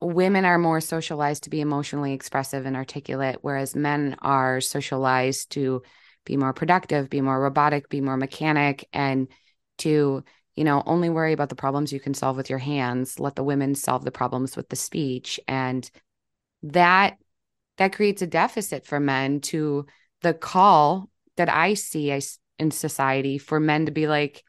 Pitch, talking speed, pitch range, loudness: 145 Hz, 170 wpm, 135-155 Hz, -24 LUFS